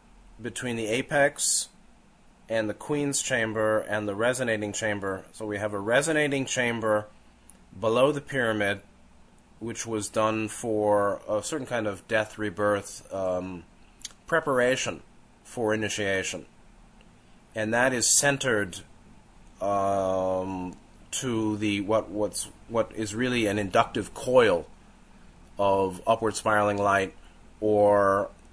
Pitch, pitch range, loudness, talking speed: 105 Hz, 100-115 Hz, -26 LUFS, 110 wpm